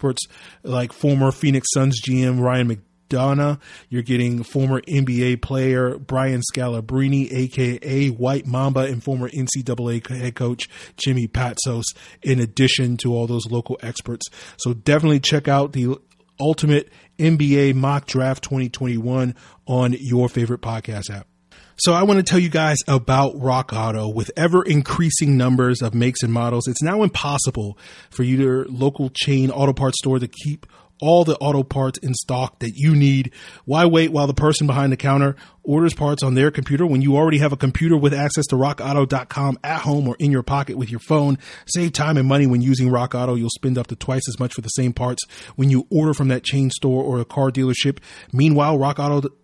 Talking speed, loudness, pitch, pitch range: 180 wpm, -19 LUFS, 130 Hz, 125-140 Hz